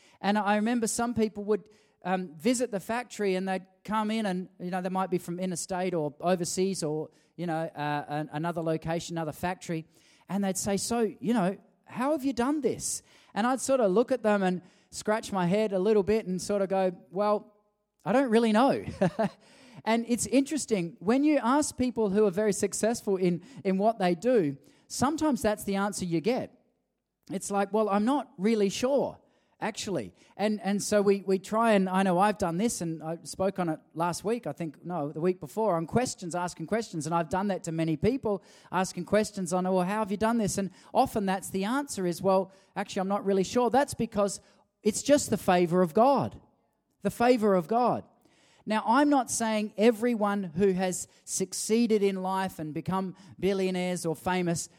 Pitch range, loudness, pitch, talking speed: 180-220 Hz, -28 LUFS, 200 Hz, 200 wpm